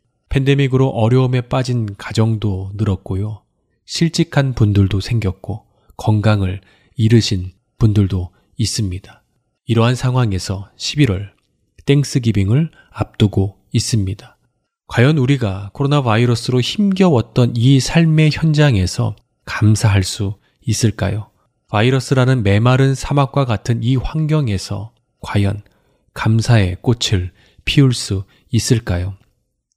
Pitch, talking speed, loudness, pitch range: 115 Hz, 250 characters per minute, -16 LUFS, 100-130 Hz